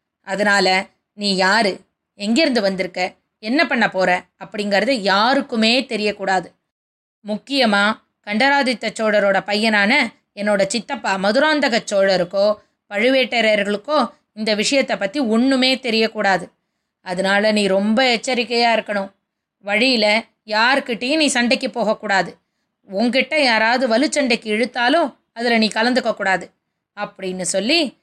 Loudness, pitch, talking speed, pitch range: -17 LUFS, 220 Hz, 95 wpm, 200-255 Hz